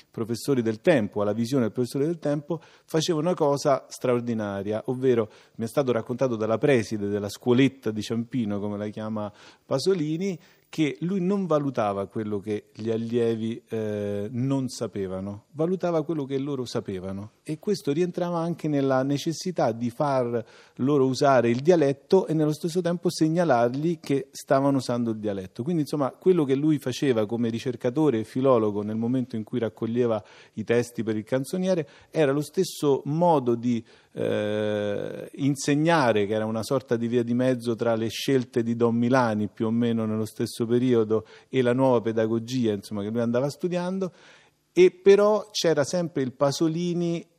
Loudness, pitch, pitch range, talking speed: -25 LUFS, 125 Hz, 115-150 Hz, 160 wpm